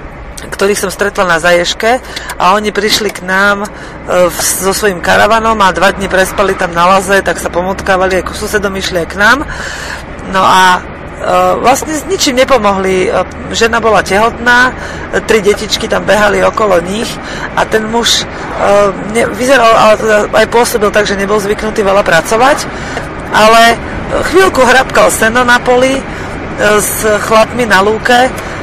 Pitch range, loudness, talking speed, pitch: 190-230 Hz, -9 LUFS, 150 wpm, 210 Hz